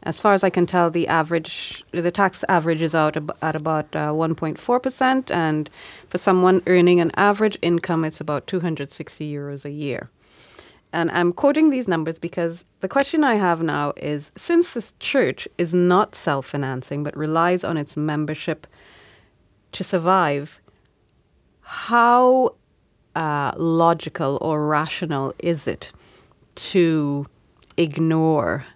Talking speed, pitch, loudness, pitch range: 135 wpm, 165 Hz, -21 LUFS, 155-185 Hz